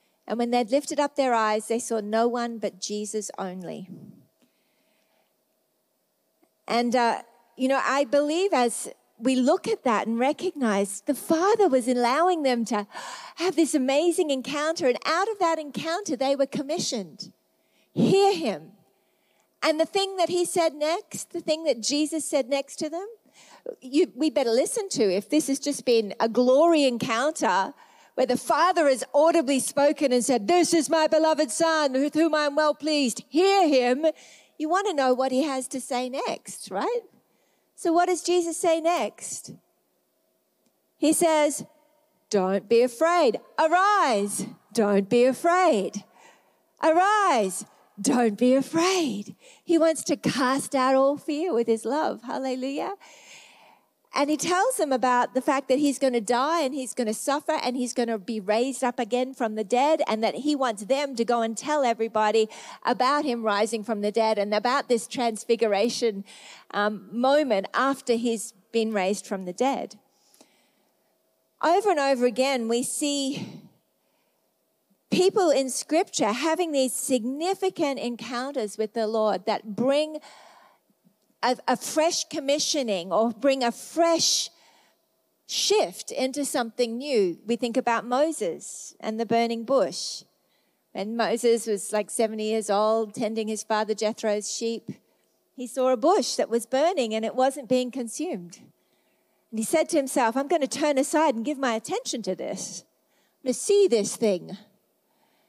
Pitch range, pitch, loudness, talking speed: 230-310 Hz, 265 Hz, -25 LUFS, 160 wpm